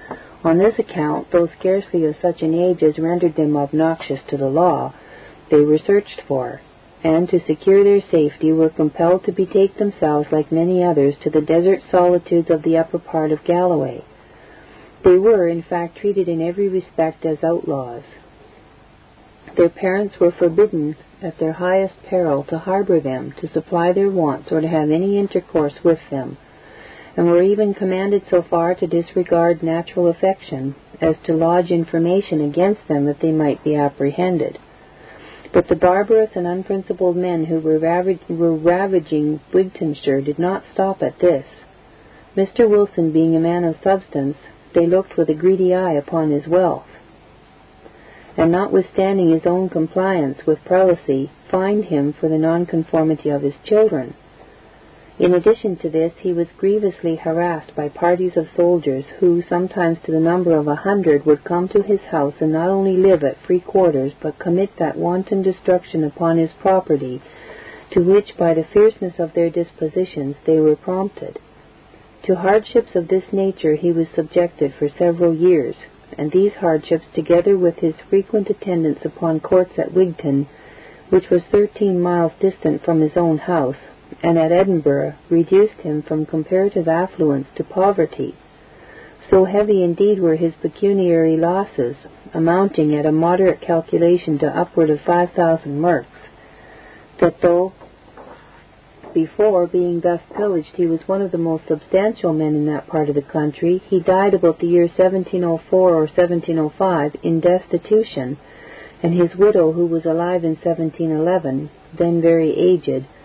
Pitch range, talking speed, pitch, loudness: 155-185 Hz, 160 wpm, 170 Hz, -17 LUFS